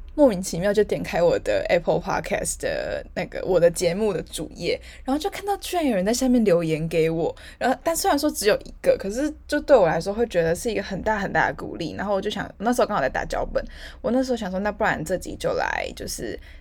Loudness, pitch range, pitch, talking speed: -23 LUFS, 185-290 Hz, 220 Hz, 385 characters per minute